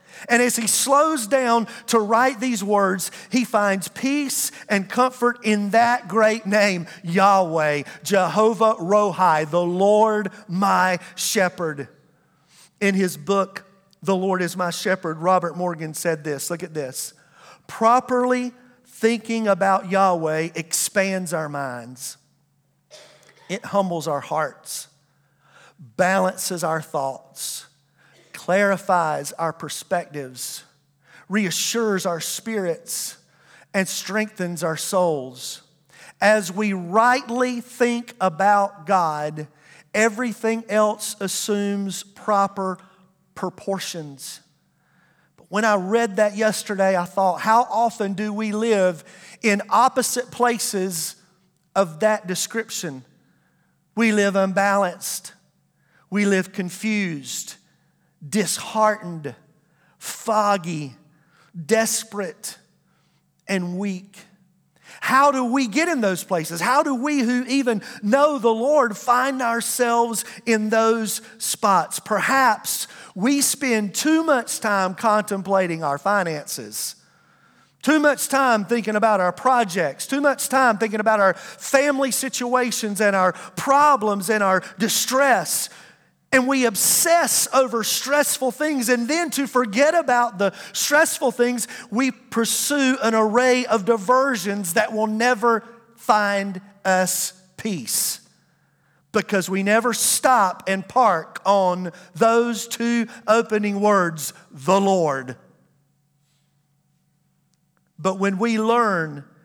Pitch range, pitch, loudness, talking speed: 180-235 Hz, 200 Hz, -21 LUFS, 110 wpm